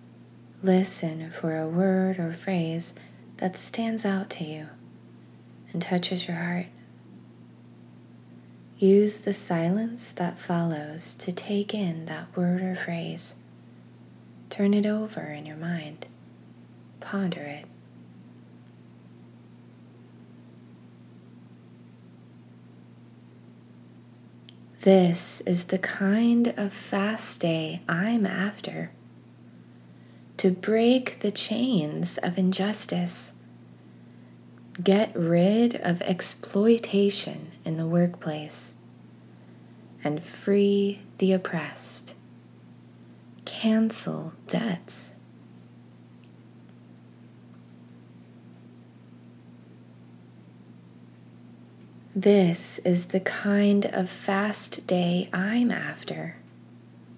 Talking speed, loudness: 75 wpm, -25 LUFS